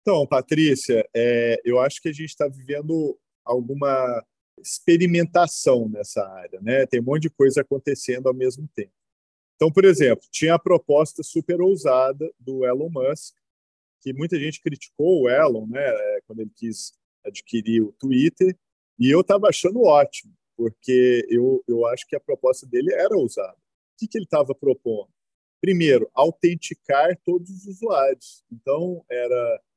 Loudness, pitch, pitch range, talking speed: -21 LUFS, 145 Hz, 125-175 Hz, 155 wpm